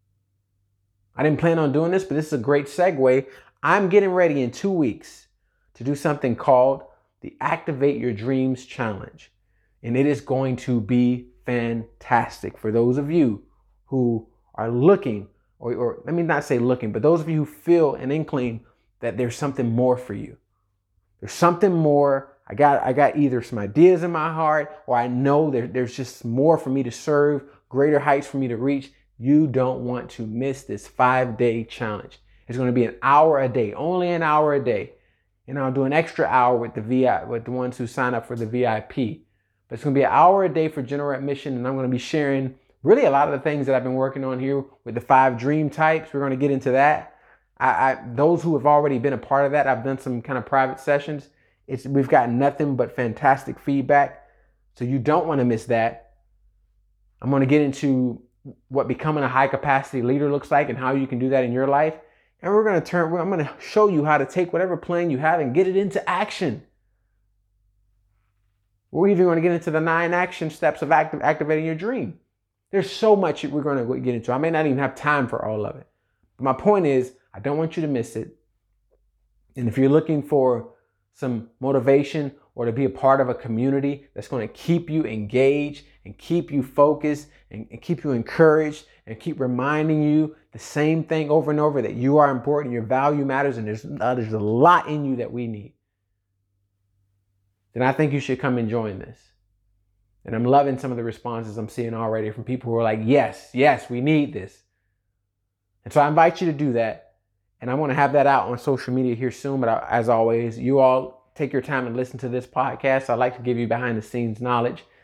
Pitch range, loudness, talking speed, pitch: 115-150 Hz, -22 LUFS, 220 wpm, 130 Hz